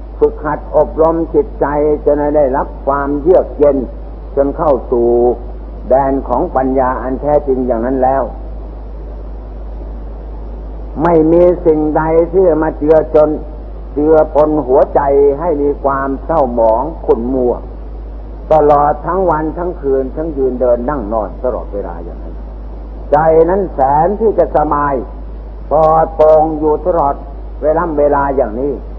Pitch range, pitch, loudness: 120-155 Hz, 145 Hz, -13 LUFS